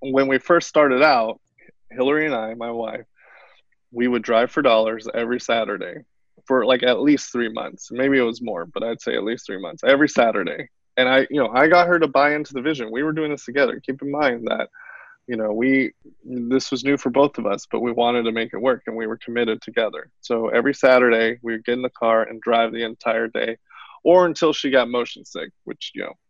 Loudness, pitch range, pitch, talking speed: -20 LUFS, 115-140 Hz, 125 Hz, 230 wpm